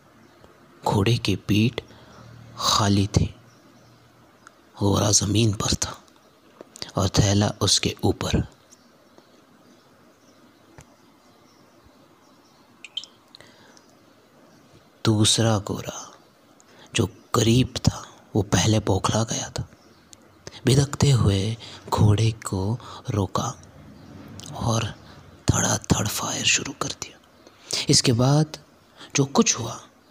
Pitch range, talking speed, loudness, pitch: 100-125 Hz, 85 wpm, -23 LUFS, 110 Hz